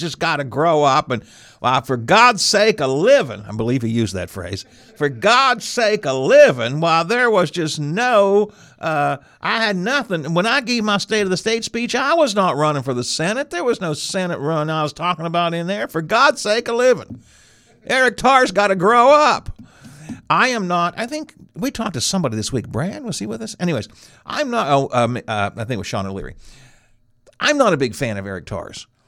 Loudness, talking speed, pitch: -17 LUFS, 220 wpm, 170 Hz